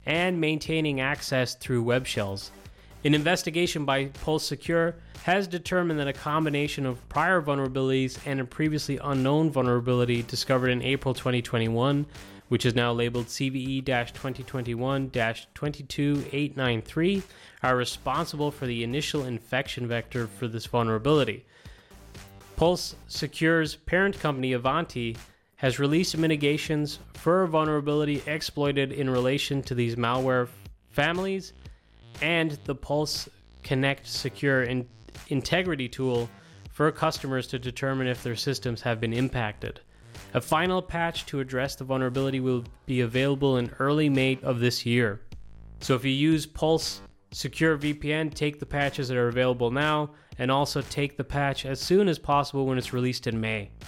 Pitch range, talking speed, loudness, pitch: 125-150 Hz, 140 wpm, -27 LUFS, 135 Hz